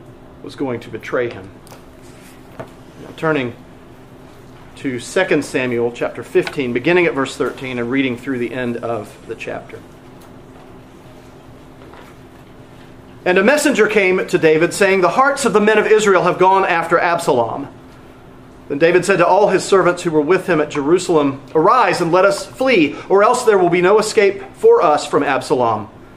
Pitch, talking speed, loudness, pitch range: 165 Hz, 165 wpm, -15 LUFS, 125-195 Hz